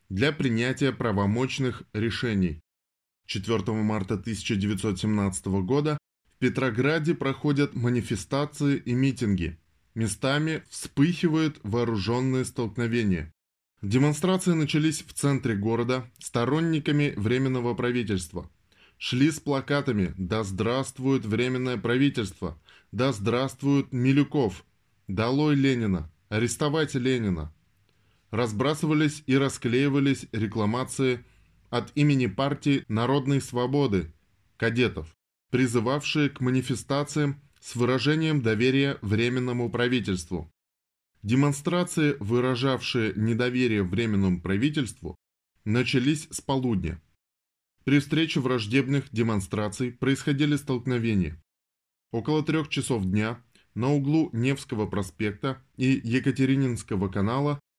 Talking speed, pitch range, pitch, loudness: 85 wpm, 100-140 Hz, 125 Hz, -26 LUFS